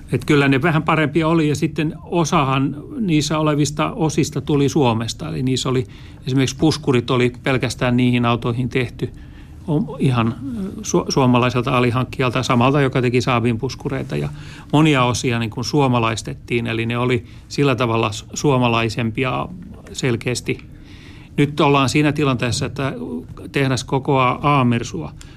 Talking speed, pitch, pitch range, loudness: 130 wpm, 130 Hz, 120-145 Hz, -19 LUFS